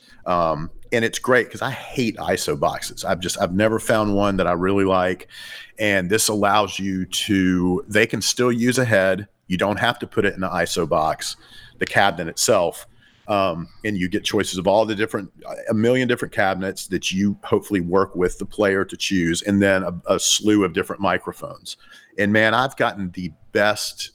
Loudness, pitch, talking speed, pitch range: -20 LUFS, 100 Hz, 195 wpm, 95-110 Hz